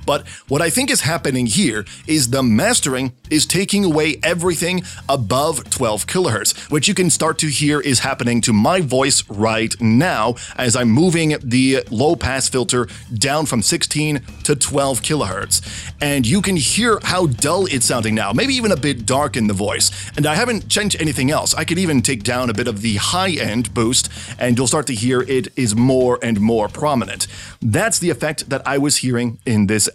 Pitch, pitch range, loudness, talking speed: 130 Hz, 115-155 Hz, -17 LUFS, 195 wpm